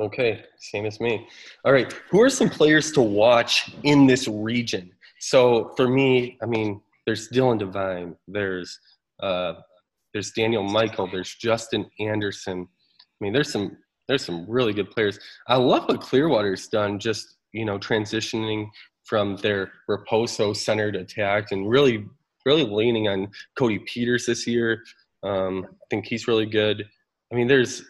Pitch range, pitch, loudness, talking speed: 100-120 Hz, 110 Hz, -23 LUFS, 155 wpm